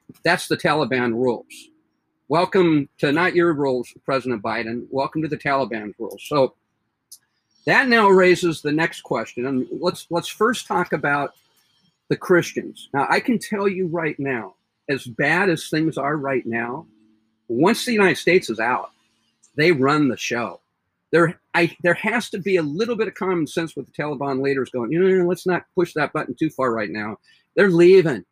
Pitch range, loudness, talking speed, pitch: 130-180 Hz, -20 LUFS, 180 wpm, 155 Hz